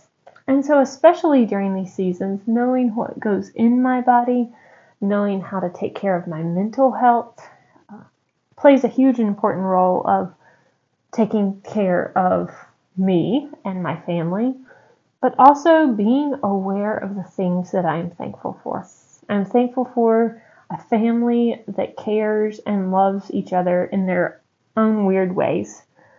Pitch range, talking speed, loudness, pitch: 190-245 Hz, 140 wpm, -19 LUFS, 215 Hz